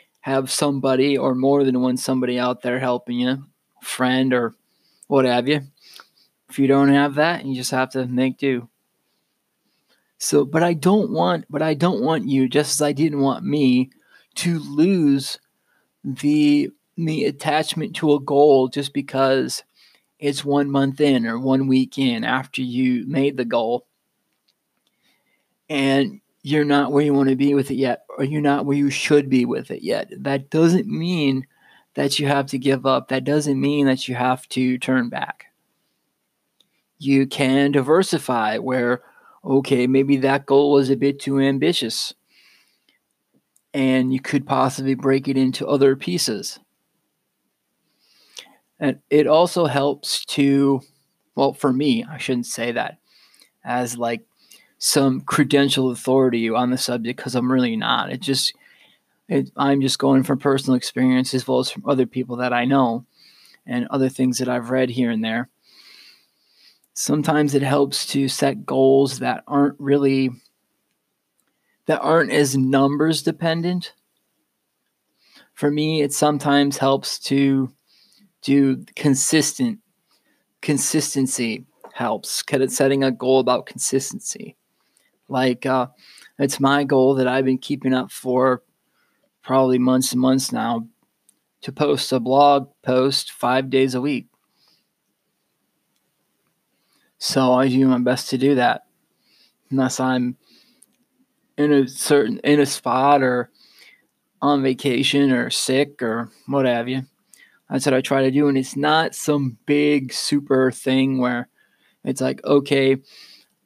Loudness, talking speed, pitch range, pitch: -20 LUFS, 145 wpm, 130-145 Hz, 135 Hz